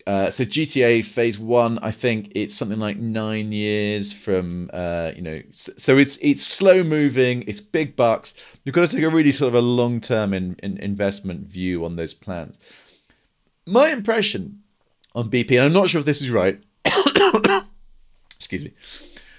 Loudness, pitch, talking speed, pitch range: -20 LUFS, 115 Hz, 175 wpm, 100-140 Hz